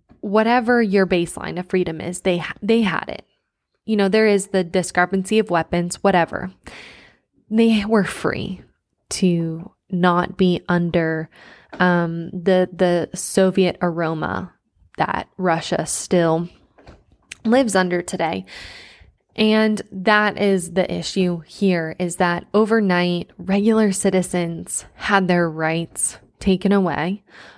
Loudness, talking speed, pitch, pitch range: -20 LUFS, 115 wpm, 185 Hz, 175-200 Hz